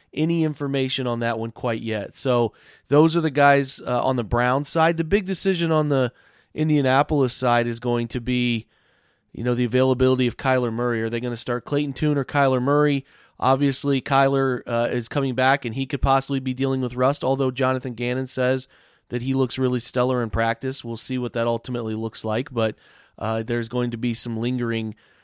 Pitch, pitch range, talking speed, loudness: 130 Hz, 120-135 Hz, 200 wpm, -22 LUFS